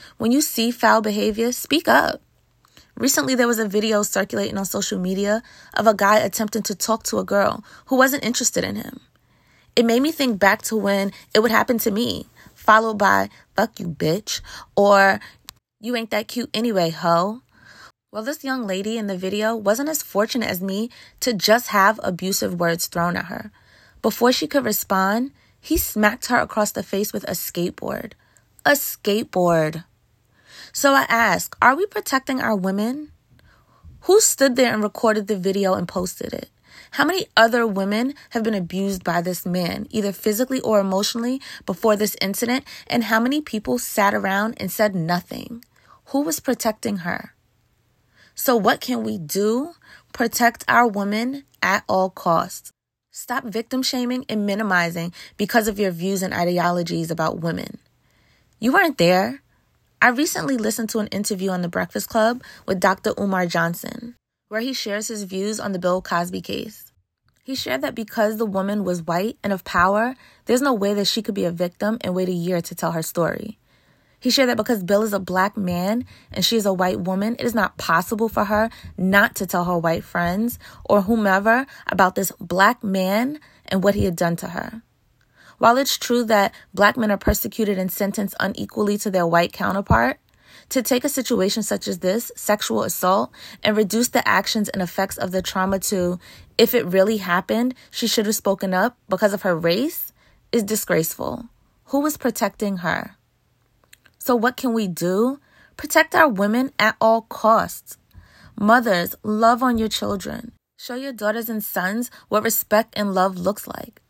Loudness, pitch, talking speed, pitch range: -21 LUFS, 215 Hz, 175 wpm, 190-235 Hz